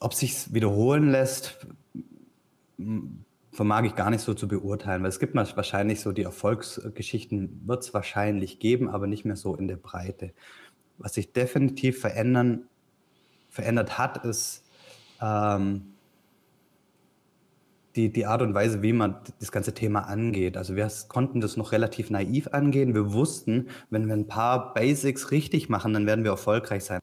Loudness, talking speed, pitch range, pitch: -27 LUFS, 160 wpm, 105-125 Hz, 110 Hz